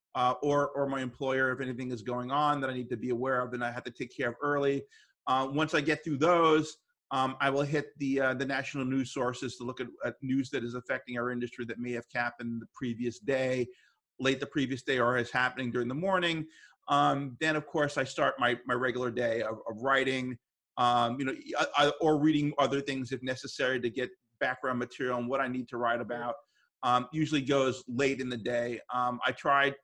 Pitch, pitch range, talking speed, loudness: 130 Hz, 125-140 Hz, 225 wpm, -31 LUFS